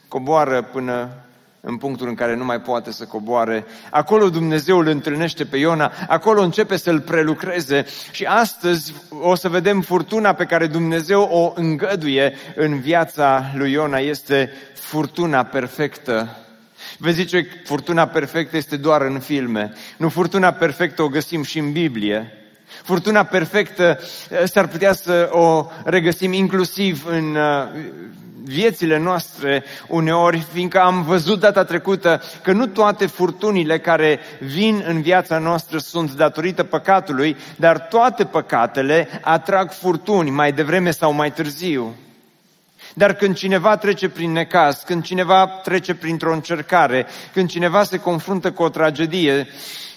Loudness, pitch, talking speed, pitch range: -18 LUFS, 165 Hz, 135 wpm, 145-185 Hz